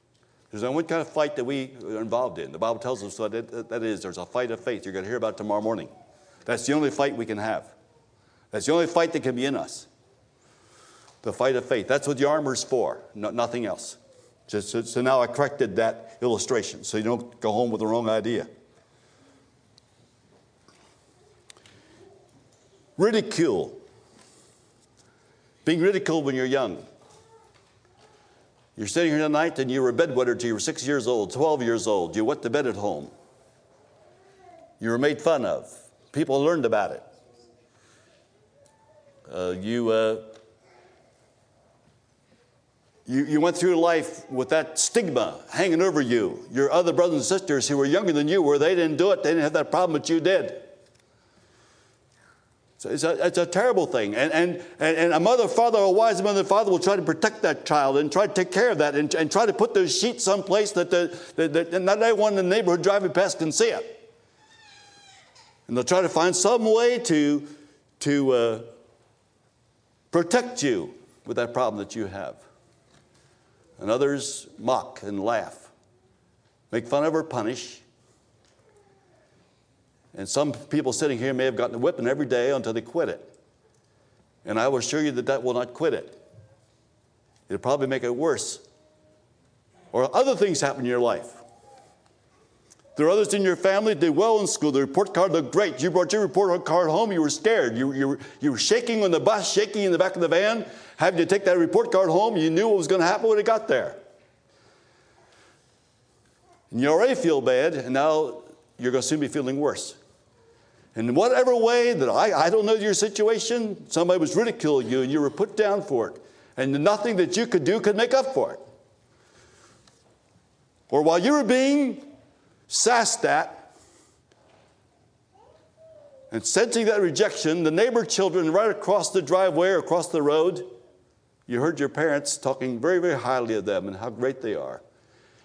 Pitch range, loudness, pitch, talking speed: 125-195 Hz, -24 LUFS, 155 Hz, 185 wpm